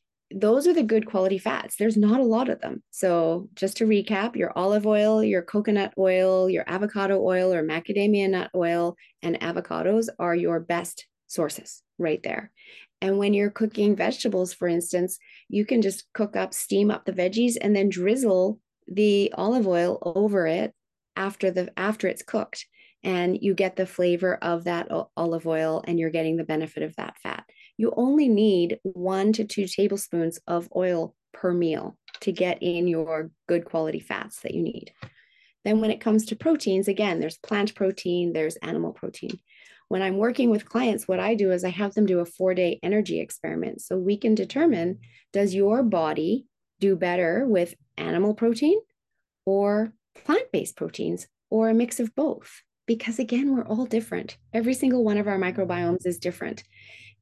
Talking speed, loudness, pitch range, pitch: 175 wpm, -25 LUFS, 175-220 Hz, 195 Hz